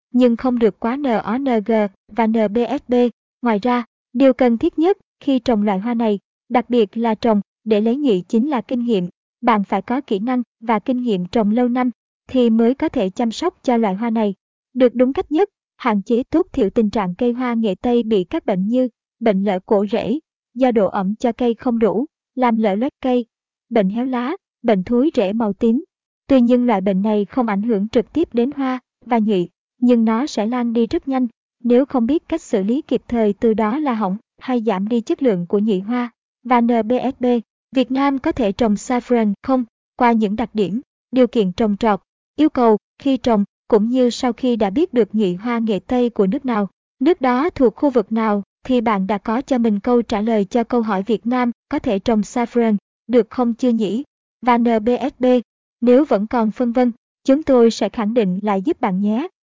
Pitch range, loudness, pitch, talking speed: 215-255 Hz, -18 LUFS, 240 Hz, 215 wpm